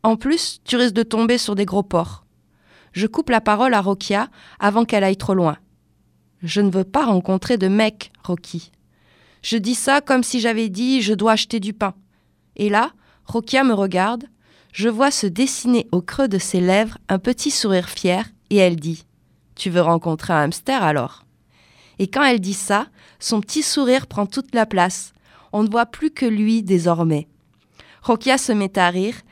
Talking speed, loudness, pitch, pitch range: 190 wpm, -19 LUFS, 210 Hz, 185-245 Hz